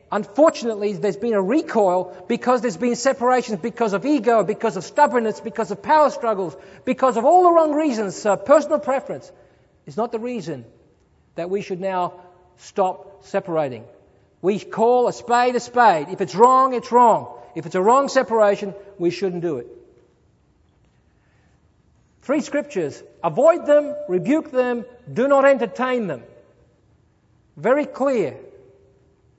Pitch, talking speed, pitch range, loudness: 230 Hz, 145 wpm, 190-265 Hz, -20 LUFS